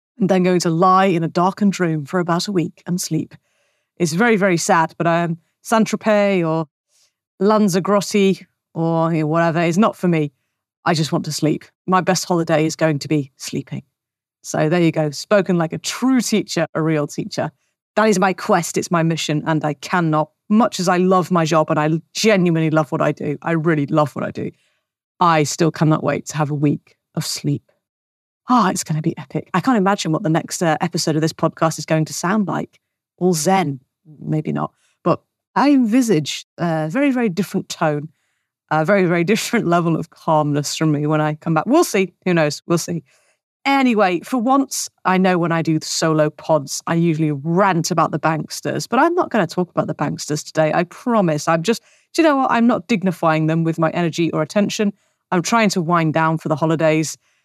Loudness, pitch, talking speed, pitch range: -18 LUFS, 165 Hz, 210 wpm, 155-190 Hz